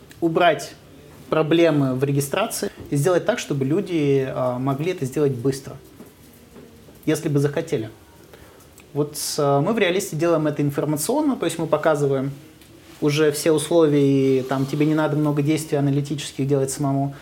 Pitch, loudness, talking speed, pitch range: 145 Hz, -21 LUFS, 135 wpm, 140-155 Hz